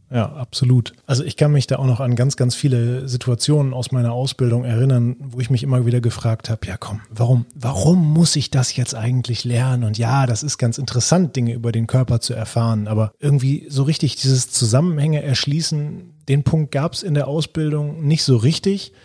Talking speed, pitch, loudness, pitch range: 200 wpm, 130 Hz, -19 LUFS, 120-145 Hz